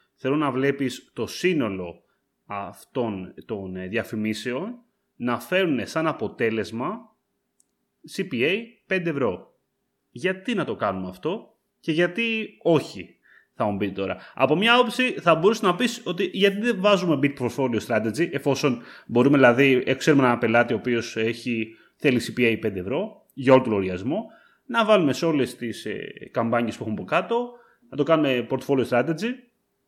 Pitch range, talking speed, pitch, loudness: 115-185 Hz, 145 wpm, 135 Hz, -23 LUFS